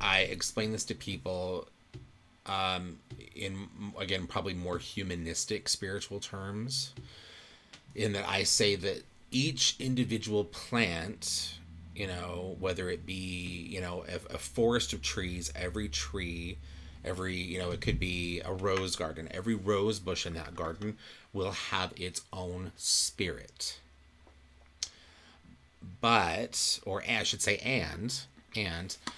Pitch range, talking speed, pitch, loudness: 85-105 Hz, 130 wpm, 90 Hz, -33 LUFS